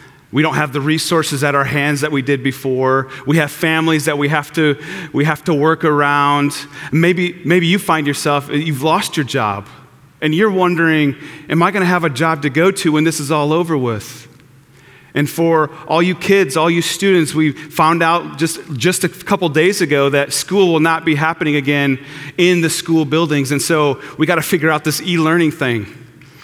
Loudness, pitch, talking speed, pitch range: -15 LUFS, 155 Hz, 205 wpm, 145-165 Hz